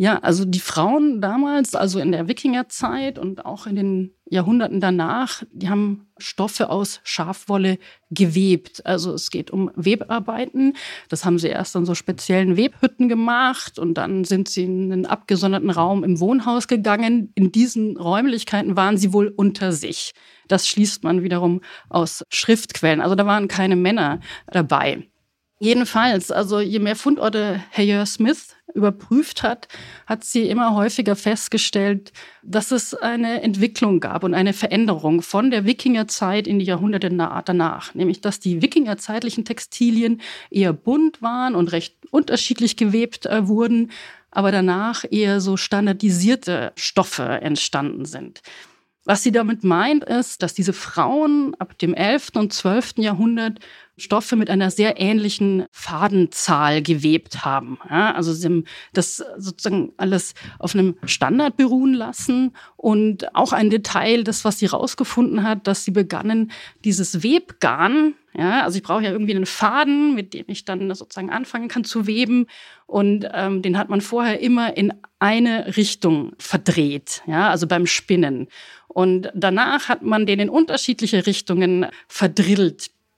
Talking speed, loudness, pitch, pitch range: 150 wpm, -20 LUFS, 205 Hz, 185-235 Hz